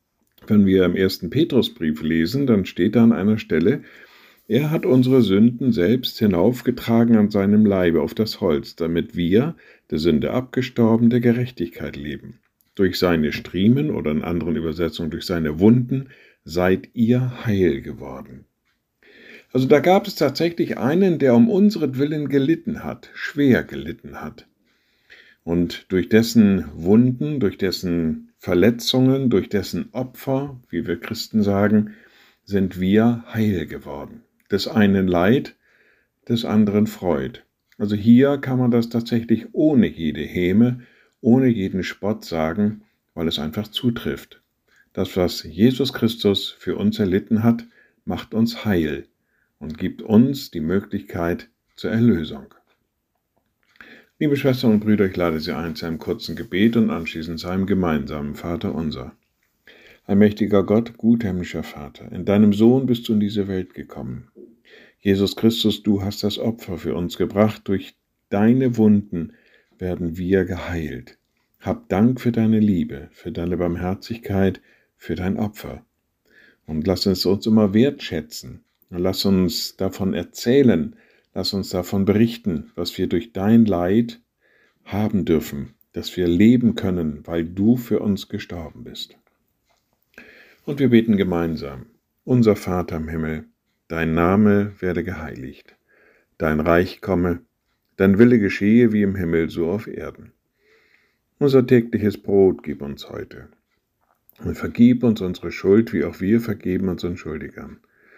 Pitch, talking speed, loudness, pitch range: 105 Hz, 140 wpm, -20 LUFS, 90-115 Hz